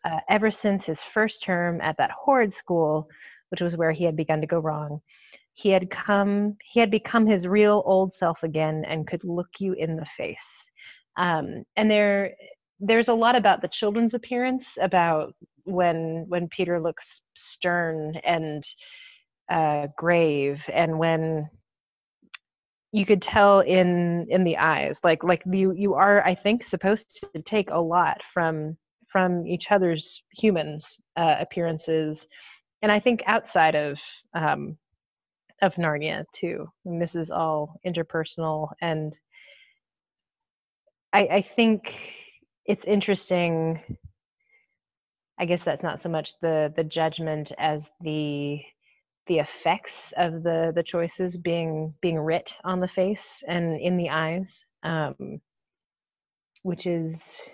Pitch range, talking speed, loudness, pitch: 160-200 Hz, 140 wpm, -24 LUFS, 175 Hz